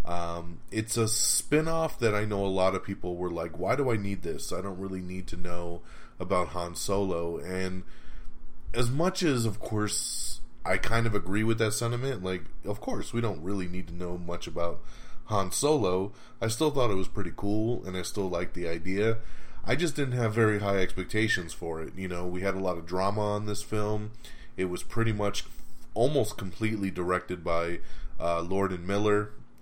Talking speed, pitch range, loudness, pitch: 200 wpm, 90-115 Hz, -30 LUFS, 100 Hz